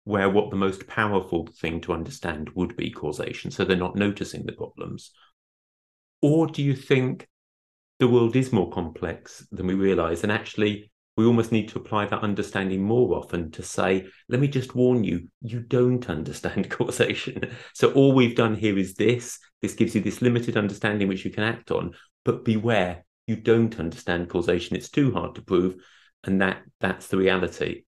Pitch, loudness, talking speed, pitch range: 105 Hz, -25 LUFS, 185 wpm, 95-120 Hz